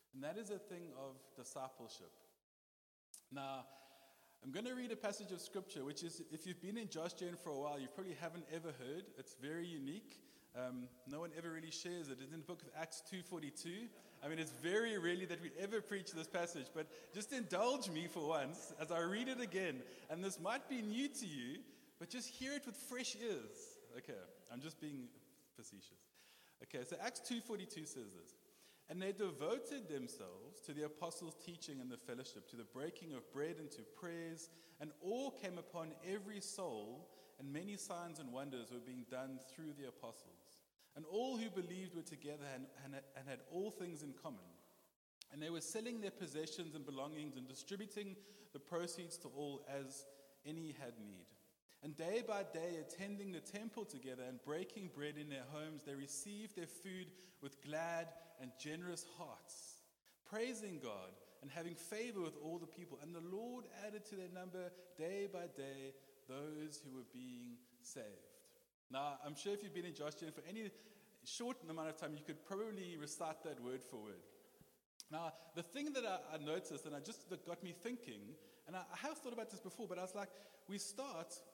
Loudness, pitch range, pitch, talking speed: -49 LUFS, 145-200 Hz, 170 Hz, 190 wpm